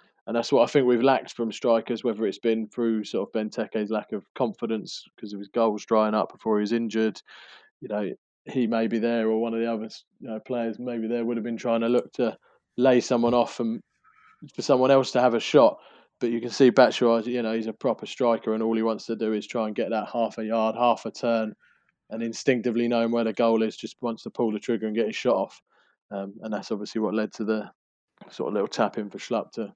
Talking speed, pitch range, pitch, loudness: 255 wpm, 110-120 Hz, 115 Hz, -25 LUFS